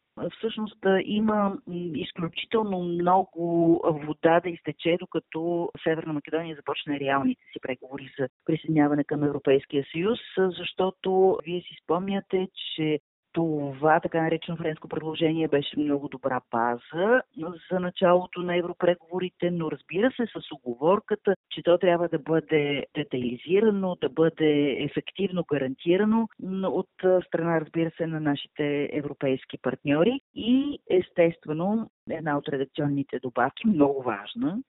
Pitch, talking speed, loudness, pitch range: 165 Hz, 120 wpm, -26 LUFS, 145-185 Hz